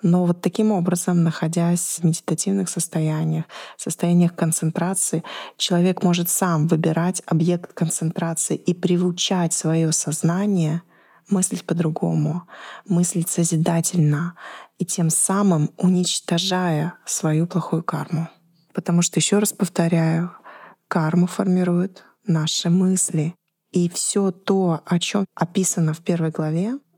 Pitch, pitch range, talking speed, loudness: 175 Hz, 165-185 Hz, 110 wpm, -21 LUFS